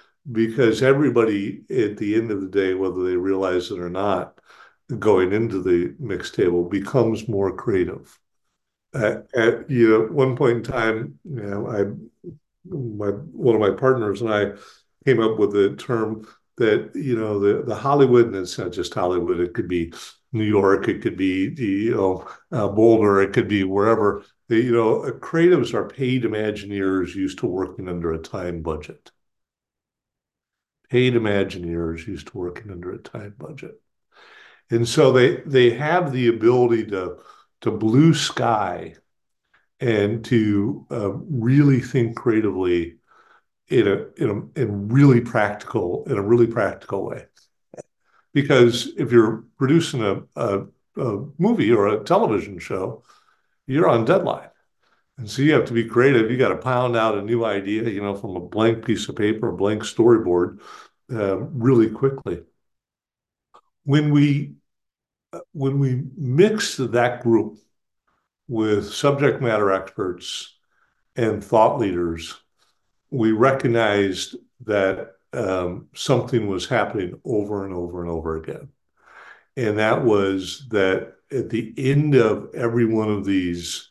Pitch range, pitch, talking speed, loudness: 100-125 Hz, 110 Hz, 145 wpm, -21 LUFS